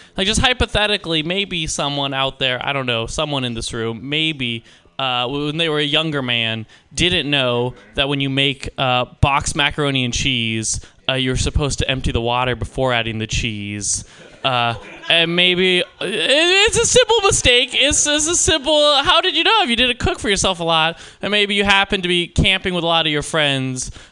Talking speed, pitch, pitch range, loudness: 205 wpm, 145 Hz, 120-190 Hz, -17 LUFS